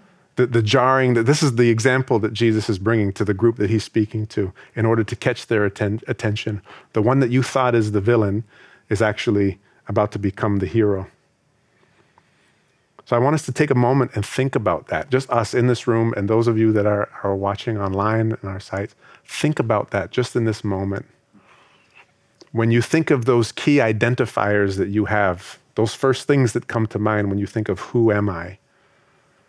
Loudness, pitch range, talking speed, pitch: -20 LUFS, 105-125 Hz, 210 wpm, 110 Hz